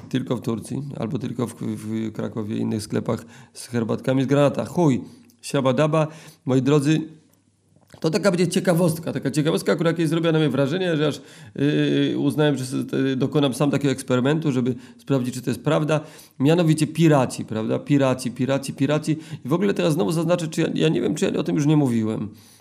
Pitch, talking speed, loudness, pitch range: 140 Hz, 190 wpm, -22 LUFS, 125-155 Hz